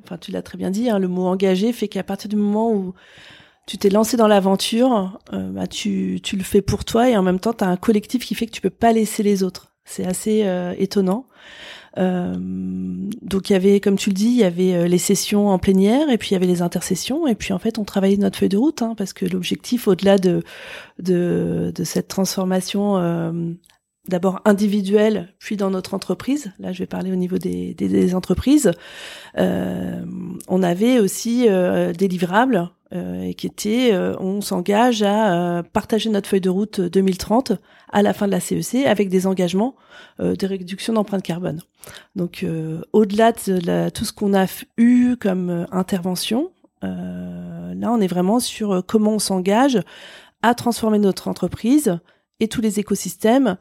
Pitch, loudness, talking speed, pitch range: 195 Hz, -20 LUFS, 195 wpm, 180-220 Hz